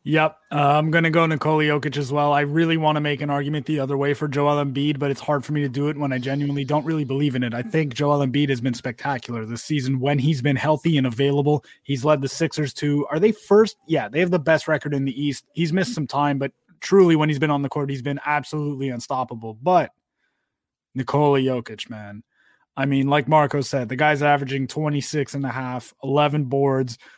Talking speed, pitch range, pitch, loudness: 230 wpm, 135-150 Hz, 145 Hz, -21 LUFS